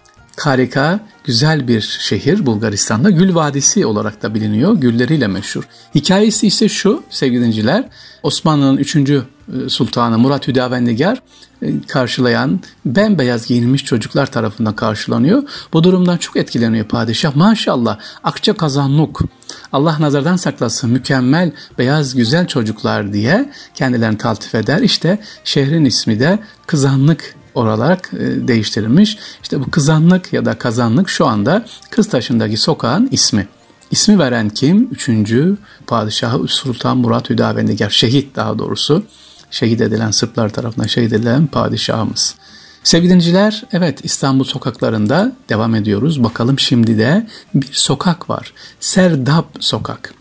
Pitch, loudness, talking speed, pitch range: 135 Hz, -14 LUFS, 120 wpm, 115-170 Hz